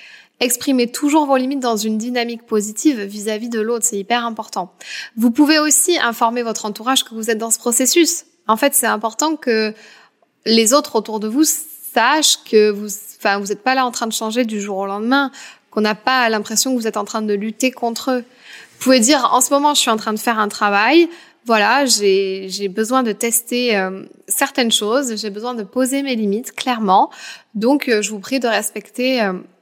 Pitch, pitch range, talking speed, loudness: 235 Hz, 215-260 Hz, 205 wpm, -17 LUFS